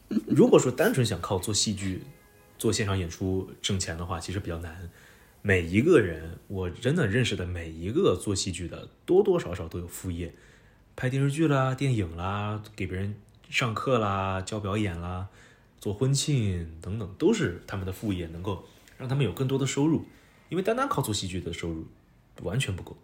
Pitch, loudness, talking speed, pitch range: 100 Hz, -28 LUFS, 275 characters per minute, 90-115 Hz